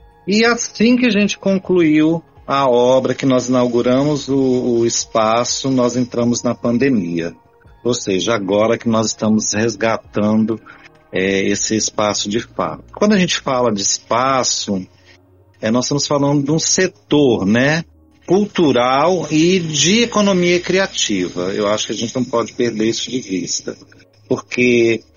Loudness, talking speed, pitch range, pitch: -16 LUFS, 145 wpm, 105-145 Hz, 120 Hz